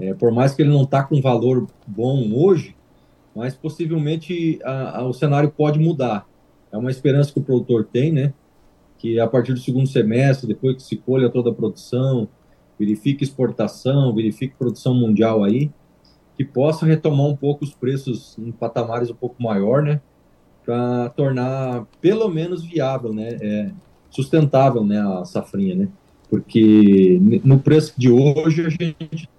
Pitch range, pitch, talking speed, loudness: 115-150 Hz, 130 Hz, 160 wpm, -19 LUFS